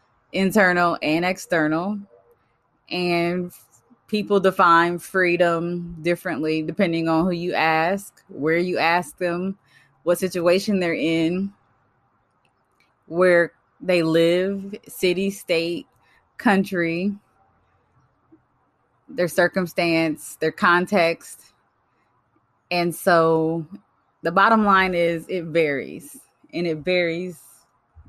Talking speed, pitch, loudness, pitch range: 90 wpm, 175 Hz, -21 LUFS, 165-190 Hz